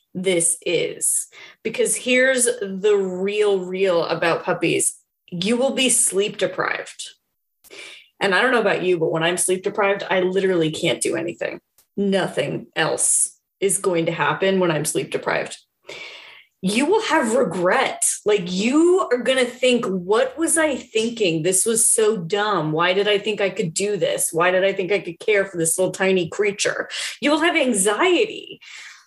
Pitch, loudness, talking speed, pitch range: 200 Hz, -20 LUFS, 170 wpm, 185-250 Hz